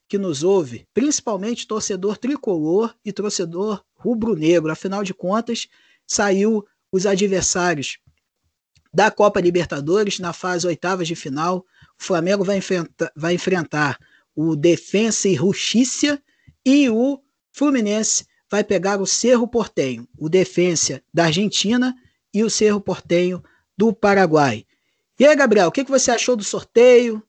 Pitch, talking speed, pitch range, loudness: 200 Hz, 130 wpm, 175-220 Hz, -19 LUFS